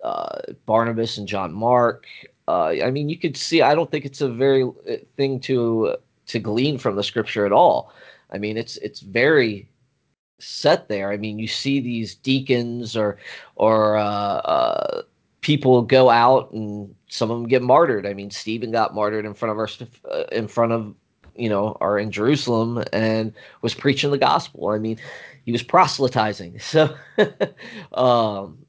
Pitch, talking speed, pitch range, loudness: 115 Hz, 170 wpm, 105-135 Hz, -21 LUFS